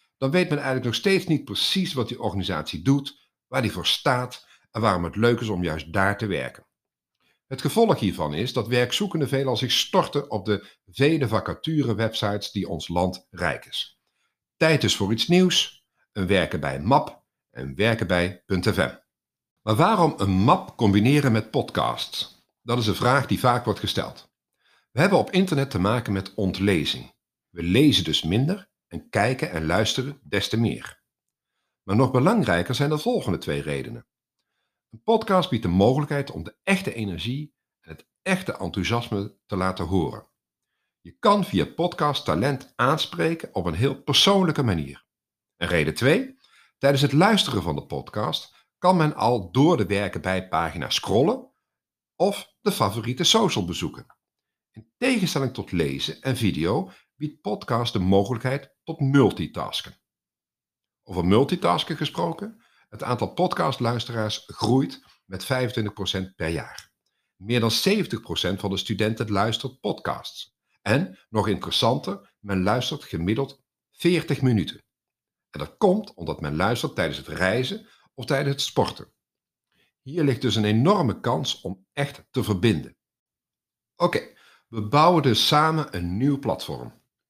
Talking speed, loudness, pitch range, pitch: 155 wpm, -24 LUFS, 100-145 Hz, 120 Hz